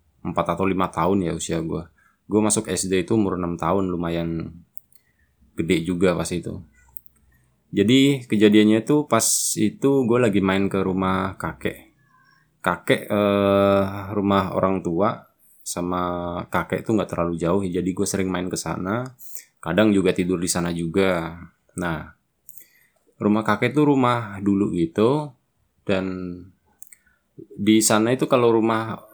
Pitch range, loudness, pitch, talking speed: 85-105 Hz, -21 LUFS, 95 Hz, 135 wpm